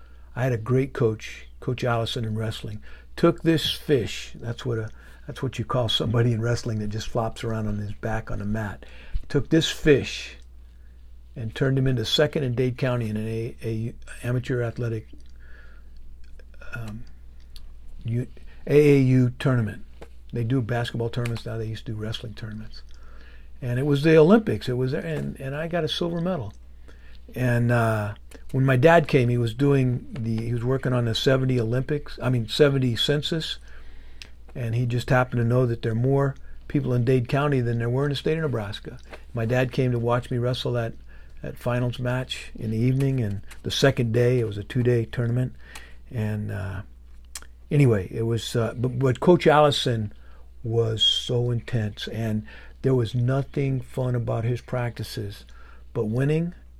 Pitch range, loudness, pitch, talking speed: 105-130 Hz, -24 LUFS, 120 Hz, 175 wpm